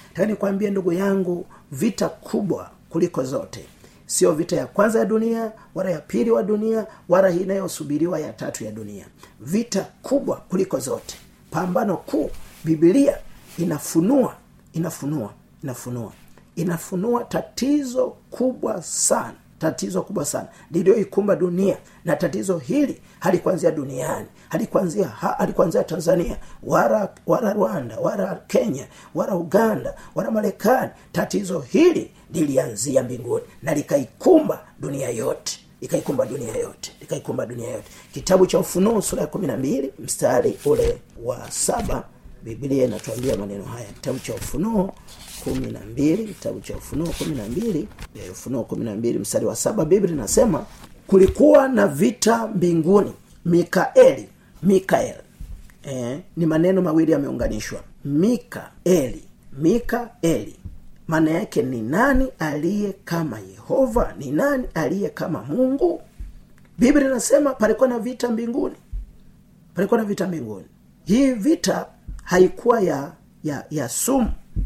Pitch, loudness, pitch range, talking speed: 190 Hz, -22 LUFS, 165-235 Hz, 115 wpm